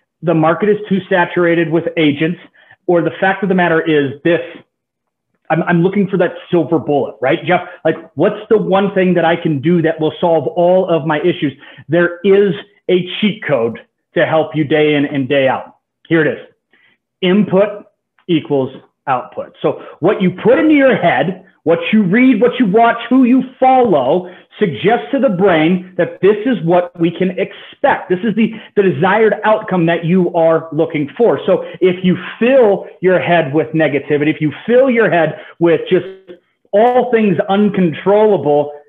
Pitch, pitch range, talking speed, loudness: 180 Hz, 160-205 Hz, 175 wpm, -14 LUFS